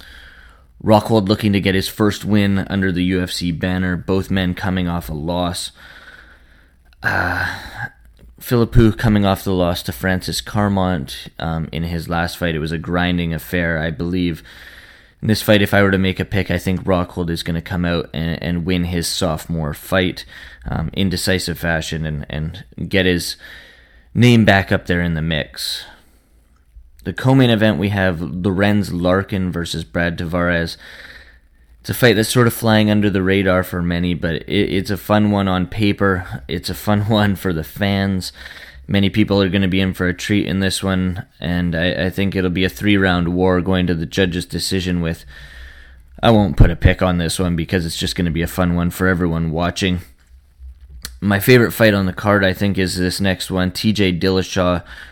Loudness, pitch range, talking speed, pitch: -18 LUFS, 85-100 Hz, 190 wpm, 90 Hz